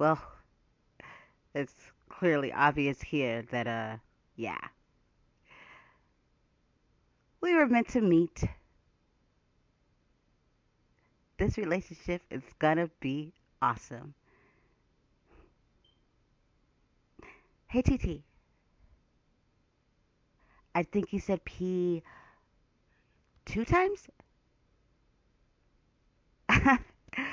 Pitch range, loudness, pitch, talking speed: 130-185 Hz, -31 LUFS, 155 Hz, 60 wpm